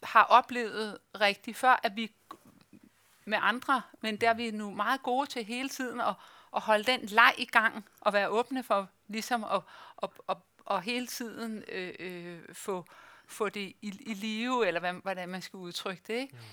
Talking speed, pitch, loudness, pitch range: 190 wpm, 220 Hz, -30 LUFS, 200-245 Hz